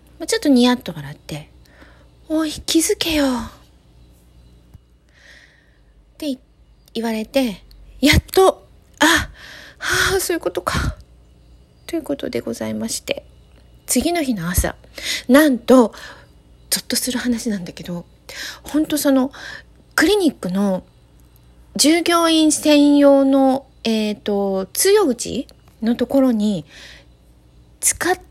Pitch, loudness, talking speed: 220 Hz, -18 LUFS, 205 characters per minute